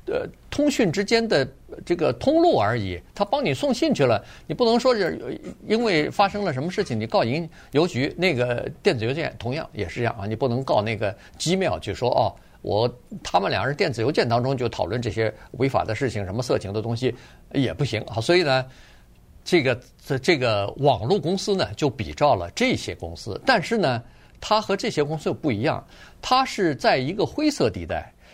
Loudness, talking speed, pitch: -23 LUFS, 290 characters per minute, 135 Hz